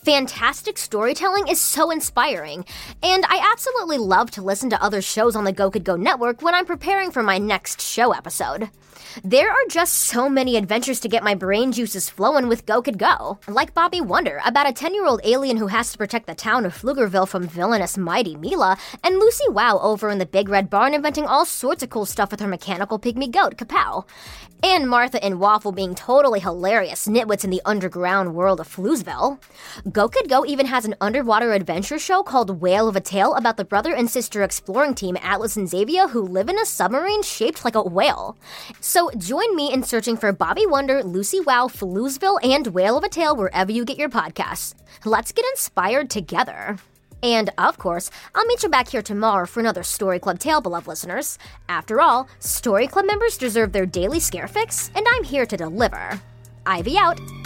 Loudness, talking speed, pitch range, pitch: -20 LUFS, 200 wpm, 195-290 Hz, 235 Hz